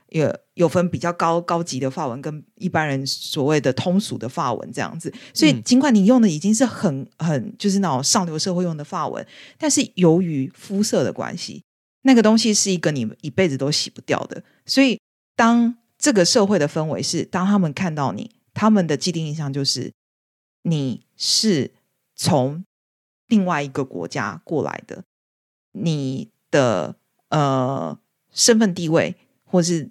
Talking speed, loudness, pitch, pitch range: 245 characters per minute, -20 LUFS, 170 Hz, 145-205 Hz